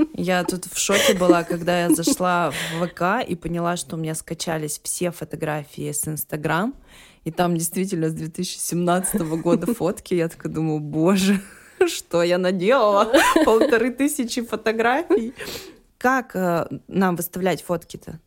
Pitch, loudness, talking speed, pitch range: 175 Hz, -21 LUFS, 135 wpm, 165-200 Hz